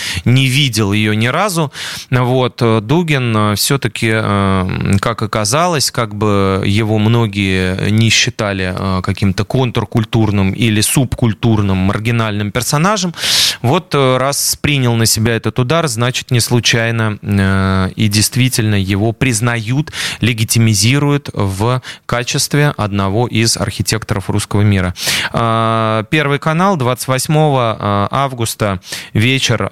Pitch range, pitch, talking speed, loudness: 105-130 Hz, 115 Hz, 100 wpm, -14 LUFS